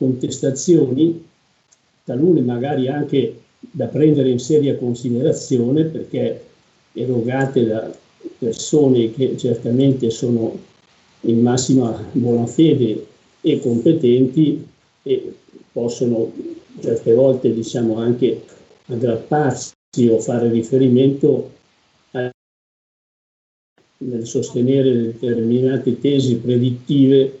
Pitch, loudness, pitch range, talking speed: 130 Hz, -18 LUFS, 120-145 Hz, 85 wpm